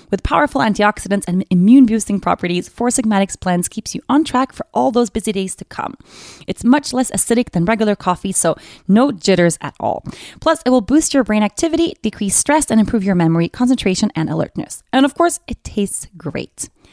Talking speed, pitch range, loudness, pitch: 195 wpm, 195-260 Hz, -16 LUFS, 220 Hz